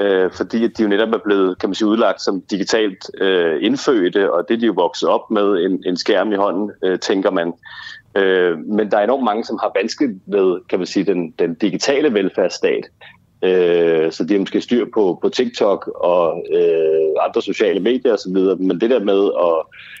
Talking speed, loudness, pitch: 200 wpm, -17 LUFS, 375 Hz